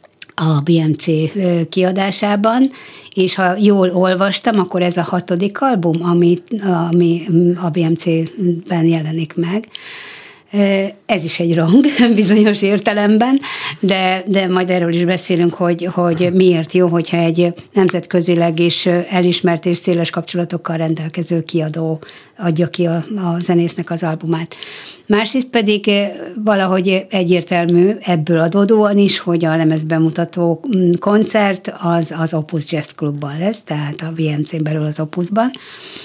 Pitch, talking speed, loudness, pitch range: 175 Hz, 125 wpm, -15 LUFS, 170-195 Hz